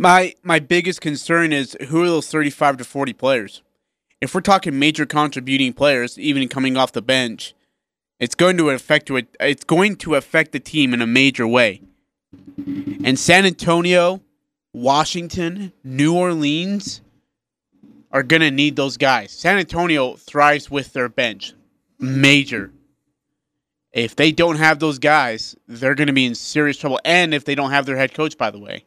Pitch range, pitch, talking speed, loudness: 135-170 Hz, 150 Hz, 165 wpm, -17 LUFS